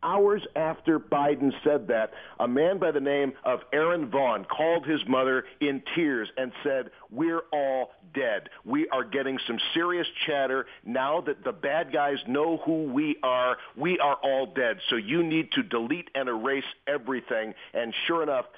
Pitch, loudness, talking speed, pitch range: 145 Hz, -27 LUFS, 170 wpm, 130-165 Hz